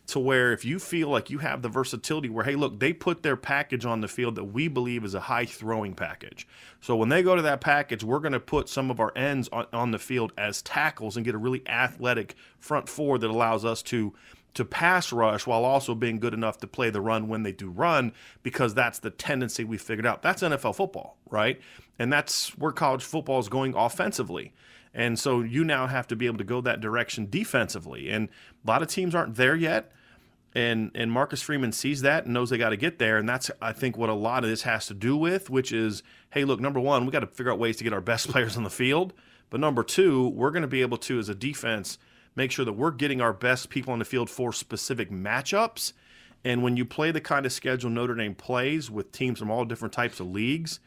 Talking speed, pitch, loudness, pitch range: 245 wpm, 125 Hz, -27 LUFS, 115-140 Hz